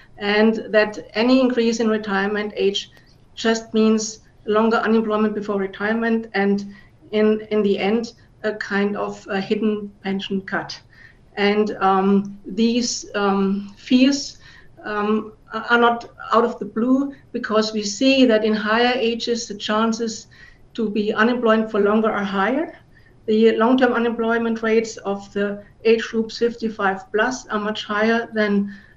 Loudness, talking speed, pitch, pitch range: -20 LUFS, 140 wpm, 215 Hz, 205-230 Hz